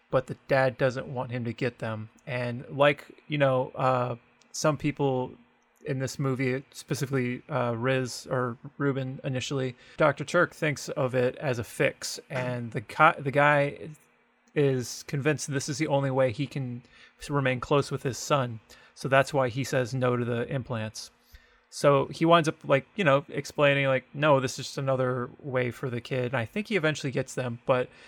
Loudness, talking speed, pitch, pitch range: -28 LUFS, 190 wpm, 135 Hz, 125-145 Hz